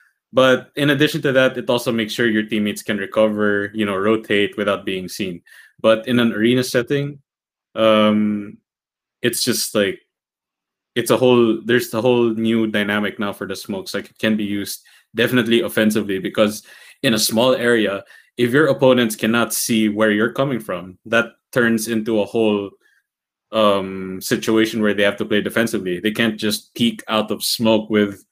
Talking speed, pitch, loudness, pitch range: 175 wpm, 110 Hz, -18 LUFS, 105-120 Hz